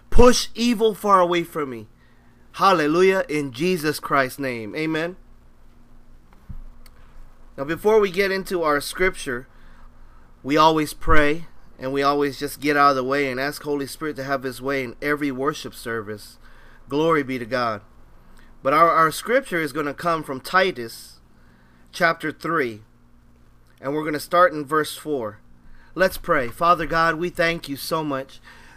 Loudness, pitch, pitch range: -21 LUFS, 145 Hz, 120-165 Hz